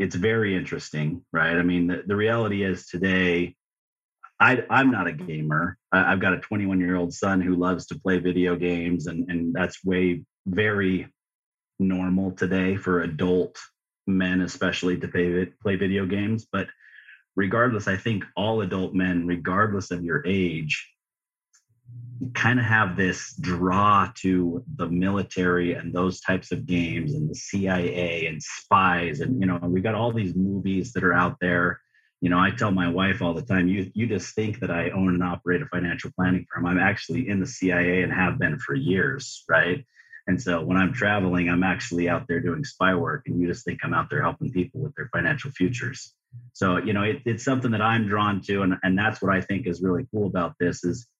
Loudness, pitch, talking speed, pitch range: -24 LUFS, 95 Hz, 195 wpm, 90-100 Hz